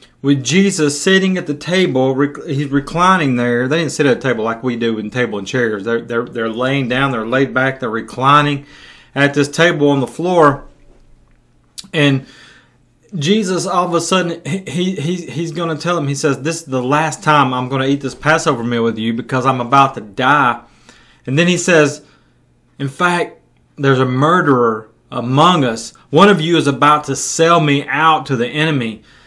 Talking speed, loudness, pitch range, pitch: 195 wpm, -15 LUFS, 125-160 Hz, 140 Hz